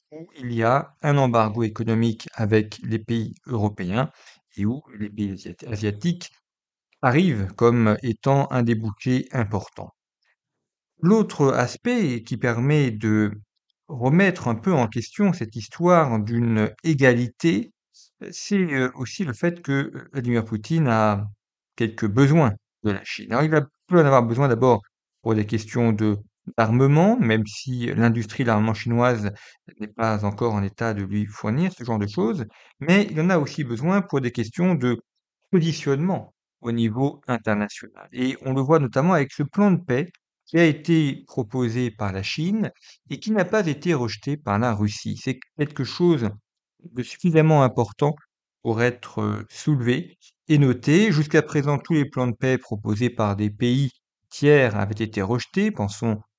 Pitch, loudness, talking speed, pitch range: 125 Hz, -22 LUFS, 155 wpm, 110-150 Hz